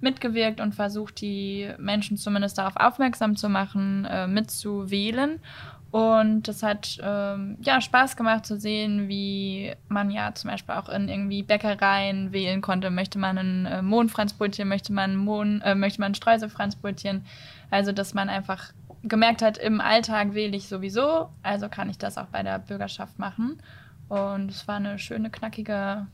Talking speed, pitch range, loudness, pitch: 160 wpm, 195-215 Hz, -26 LUFS, 205 Hz